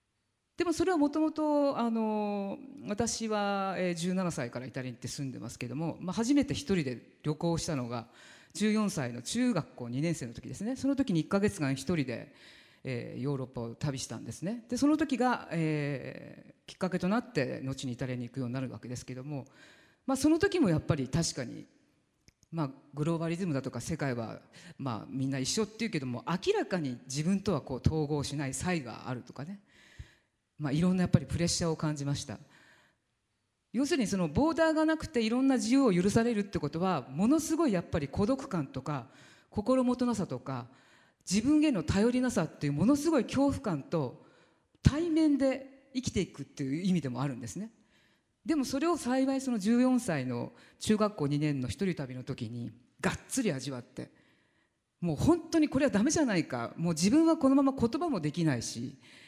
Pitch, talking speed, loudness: 170 Hz, 360 characters per minute, -31 LUFS